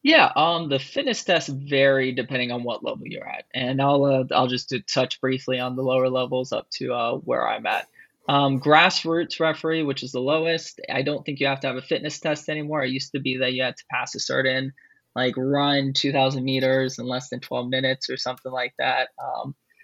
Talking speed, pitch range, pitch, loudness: 220 wpm, 130-150 Hz, 135 Hz, -23 LUFS